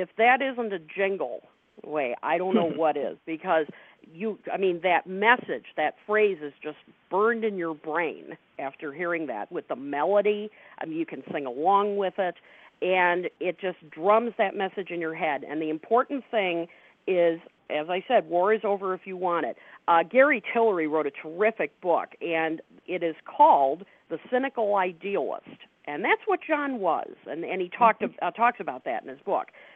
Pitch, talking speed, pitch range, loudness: 190 Hz, 190 wpm, 170-225 Hz, -26 LUFS